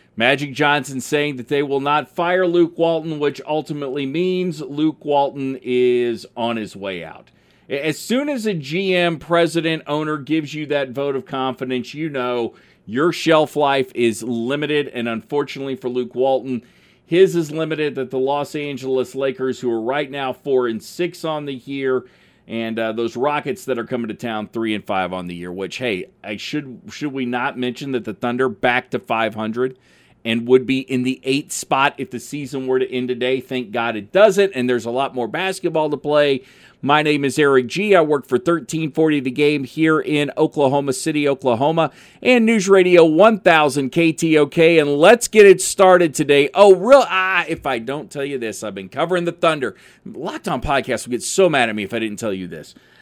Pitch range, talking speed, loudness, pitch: 125-160 Hz, 200 wpm, -18 LUFS, 140 Hz